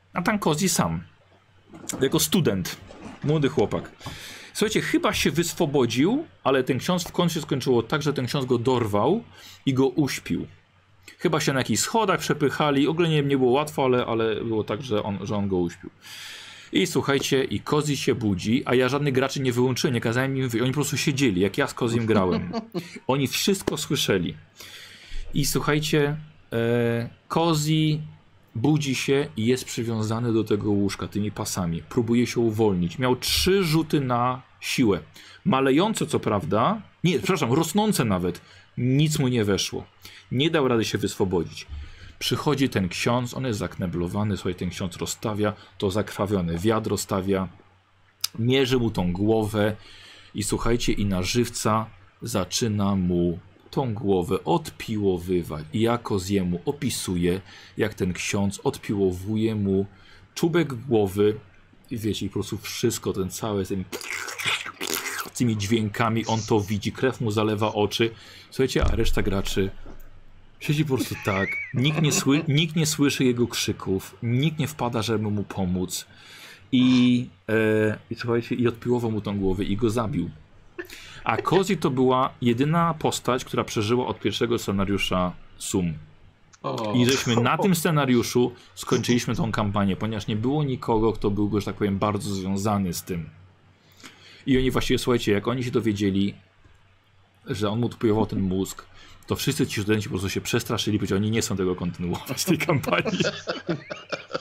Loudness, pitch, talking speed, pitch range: -24 LUFS, 110 Hz, 155 wpm, 100-130 Hz